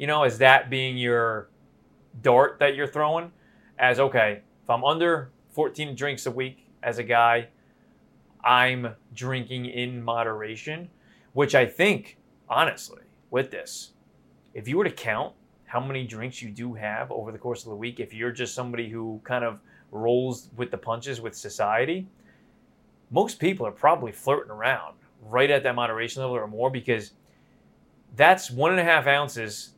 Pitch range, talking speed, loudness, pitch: 115-135 Hz, 165 wpm, -25 LUFS, 125 Hz